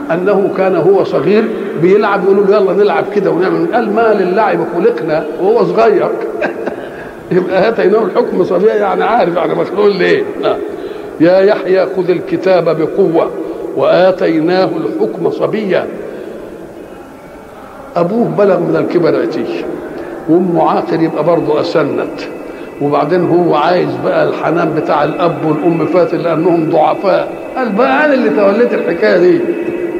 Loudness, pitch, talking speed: -12 LUFS, 200 Hz, 125 wpm